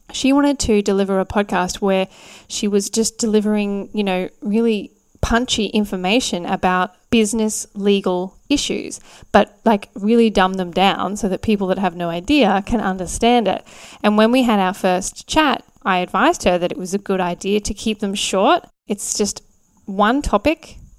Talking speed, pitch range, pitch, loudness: 170 wpm, 190-225 Hz, 205 Hz, -18 LUFS